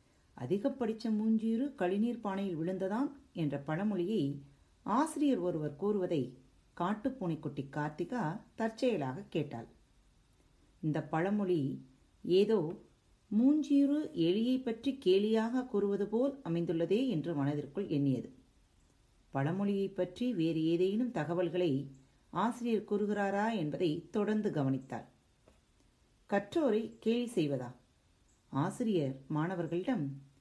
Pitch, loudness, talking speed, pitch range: 185 Hz, -34 LUFS, 85 wpm, 150-225 Hz